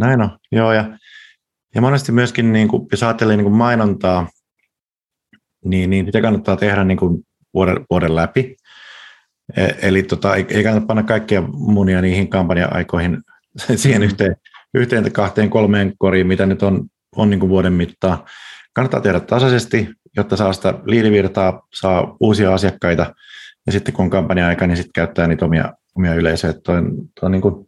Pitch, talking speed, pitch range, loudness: 95 Hz, 155 wpm, 90-110 Hz, -16 LUFS